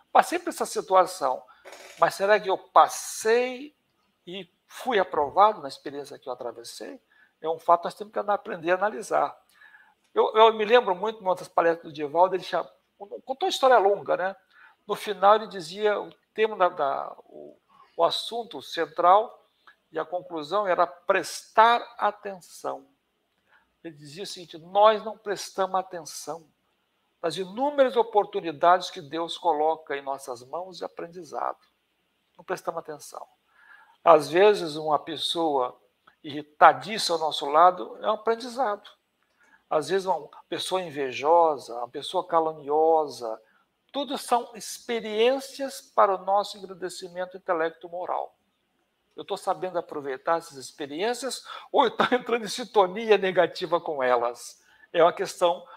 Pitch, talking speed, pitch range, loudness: 185 Hz, 140 wpm, 160-210 Hz, -25 LUFS